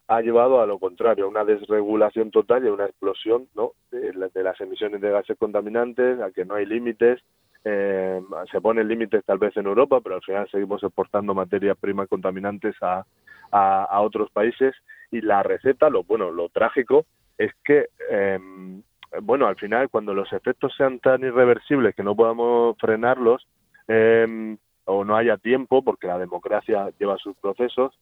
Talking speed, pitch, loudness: 175 wpm, 115 Hz, -22 LUFS